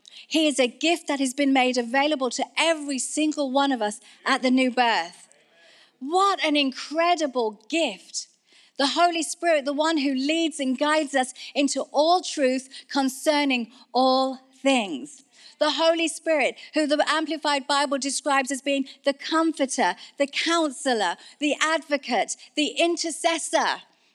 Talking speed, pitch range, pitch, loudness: 140 wpm, 265-315 Hz, 285 Hz, -24 LUFS